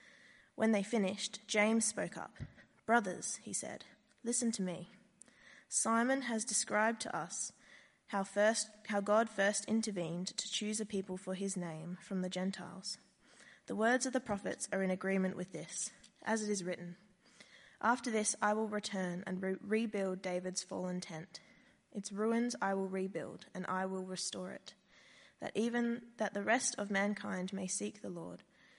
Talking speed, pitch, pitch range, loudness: 165 wpm, 205 Hz, 185-220 Hz, -37 LUFS